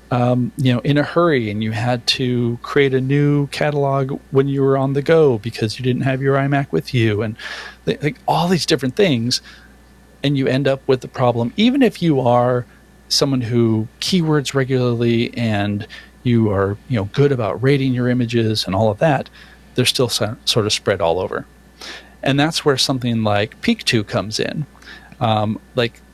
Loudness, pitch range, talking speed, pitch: -18 LUFS, 115-140 Hz, 185 wpm, 125 Hz